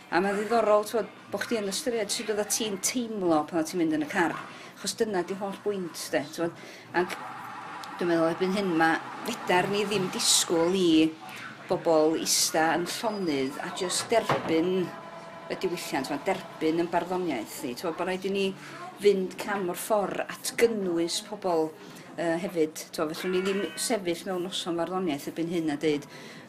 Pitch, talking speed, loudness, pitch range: 180 Hz, 155 wpm, -28 LUFS, 165-200 Hz